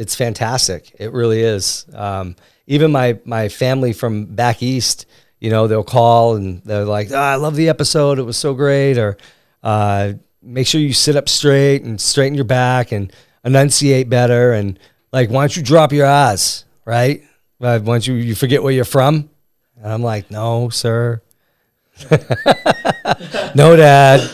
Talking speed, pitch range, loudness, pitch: 170 wpm, 110-140 Hz, -14 LUFS, 125 Hz